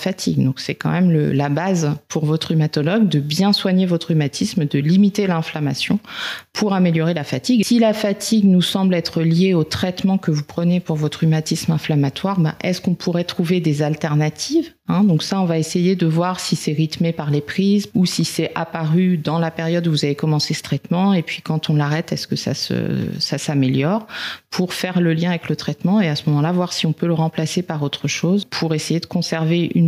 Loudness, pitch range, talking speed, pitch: -19 LUFS, 155-185 Hz, 220 wpm, 170 Hz